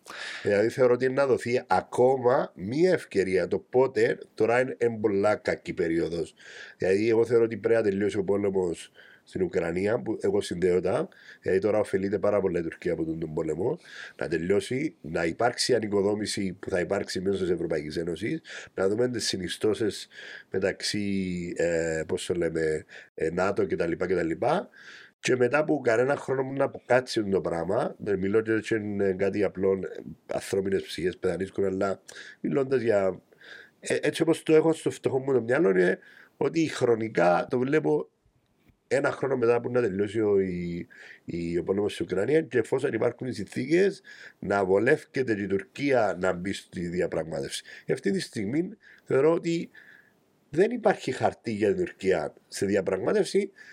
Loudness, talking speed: -27 LUFS, 150 wpm